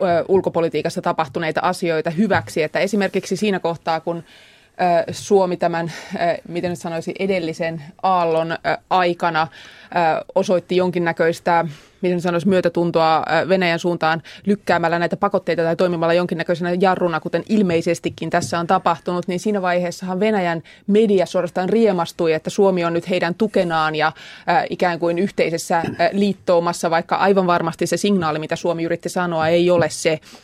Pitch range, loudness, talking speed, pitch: 165-185 Hz, -19 LUFS, 130 wpm, 175 Hz